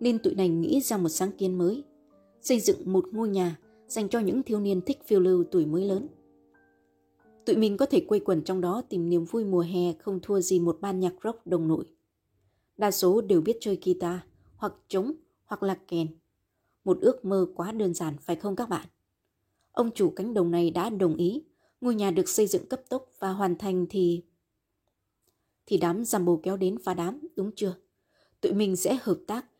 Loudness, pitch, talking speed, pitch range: -28 LUFS, 185 Hz, 205 wpm, 175-215 Hz